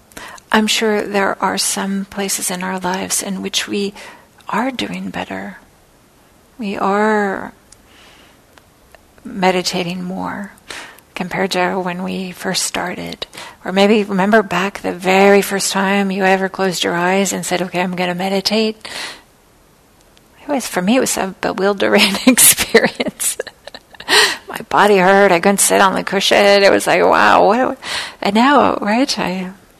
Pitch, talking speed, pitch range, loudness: 195 Hz, 145 wpm, 180-200 Hz, -15 LUFS